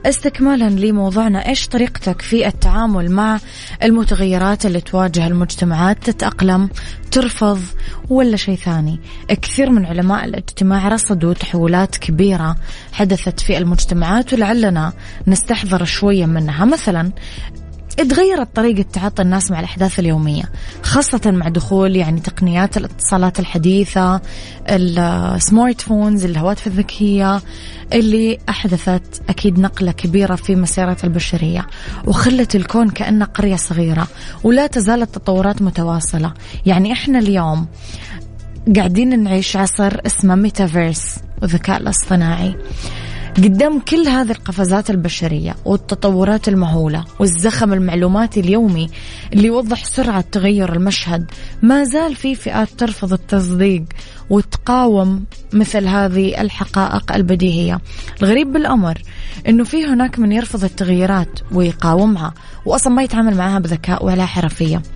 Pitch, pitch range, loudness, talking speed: 195 Hz, 175-215 Hz, -15 LUFS, 110 wpm